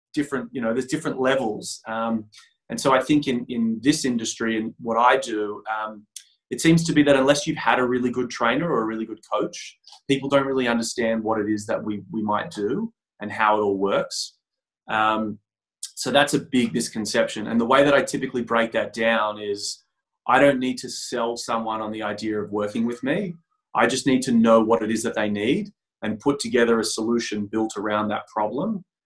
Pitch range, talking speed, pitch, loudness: 110-130 Hz, 215 wpm, 115 Hz, -23 LUFS